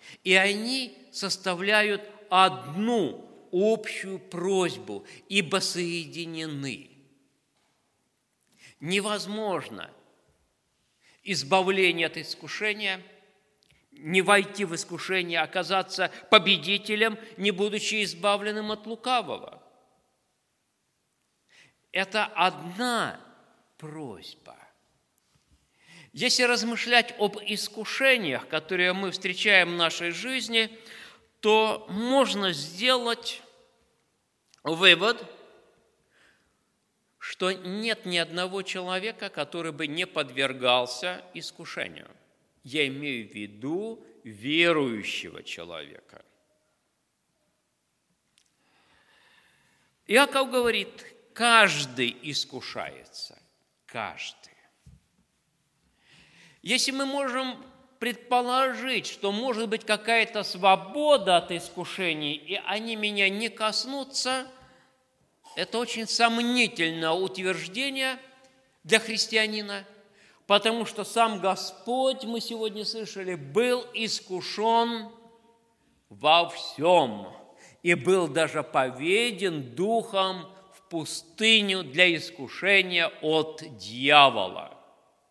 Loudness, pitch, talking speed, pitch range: -25 LUFS, 200 Hz, 75 wpm, 175-230 Hz